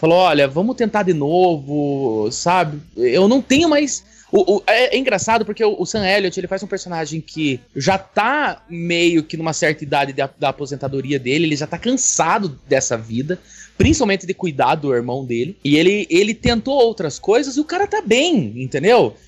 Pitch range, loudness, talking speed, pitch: 145-215 Hz, -17 LUFS, 190 wpm, 175 Hz